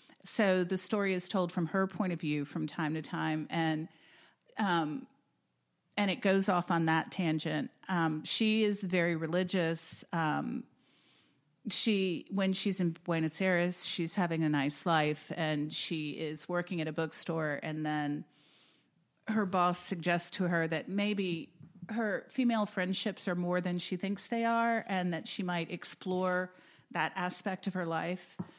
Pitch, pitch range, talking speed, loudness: 180 Hz, 160-190 Hz, 160 wpm, -33 LUFS